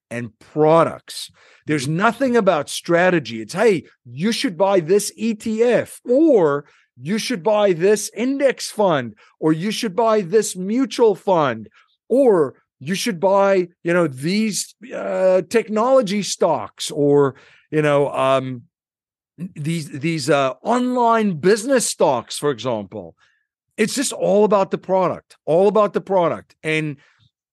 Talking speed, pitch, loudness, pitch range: 130 wpm, 190 Hz, -19 LUFS, 150-220 Hz